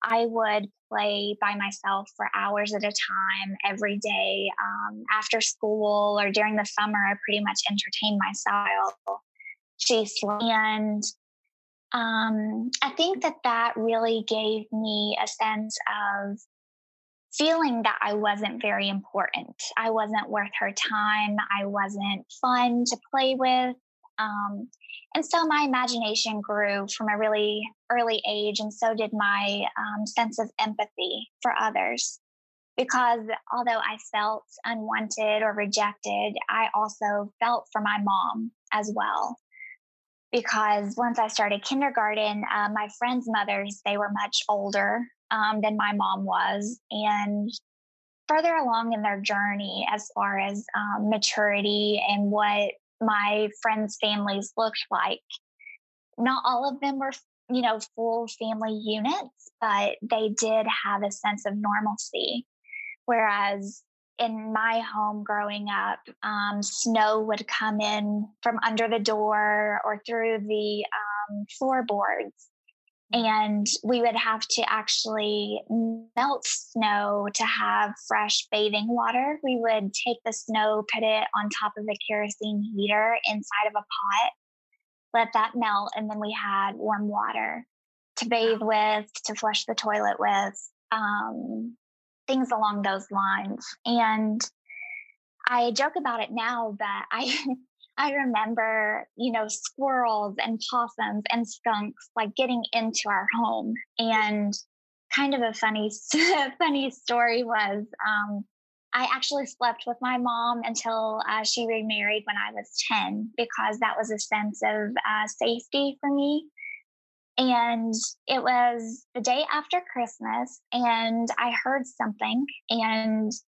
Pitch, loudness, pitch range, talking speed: 220 Hz, -26 LUFS, 210-235 Hz, 135 wpm